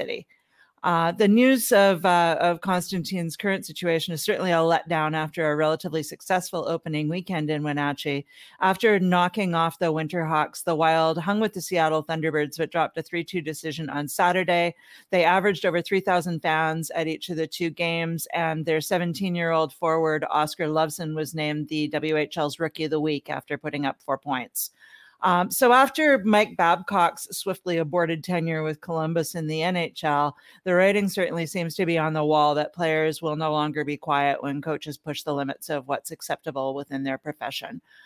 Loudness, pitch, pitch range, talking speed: -24 LUFS, 165 Hz, 155-180 Hz, 180 wpm